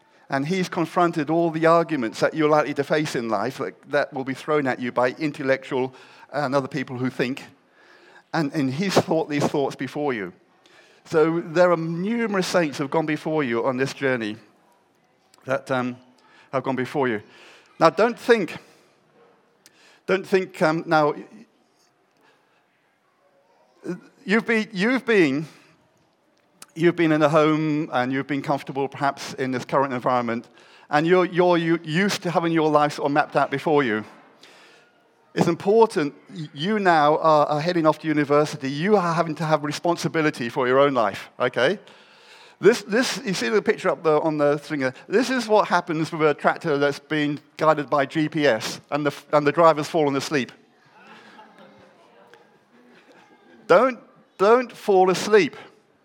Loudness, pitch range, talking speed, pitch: -22 LUFS, 140-175 Hz, 155 wpm, 155 Hz